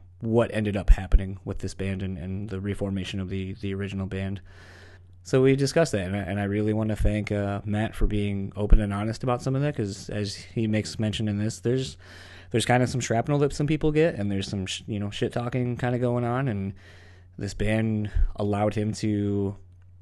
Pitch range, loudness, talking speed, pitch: 95-115 Hz, -27 LUFS, 220 wpm, 105 Hz